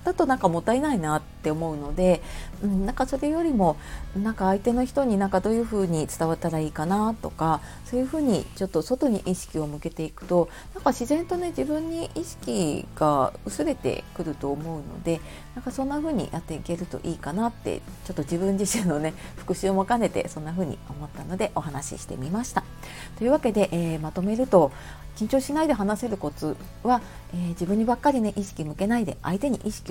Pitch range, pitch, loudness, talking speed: 160-245 Hz, 195 Hz, -26 LUFS, 405 characters per minute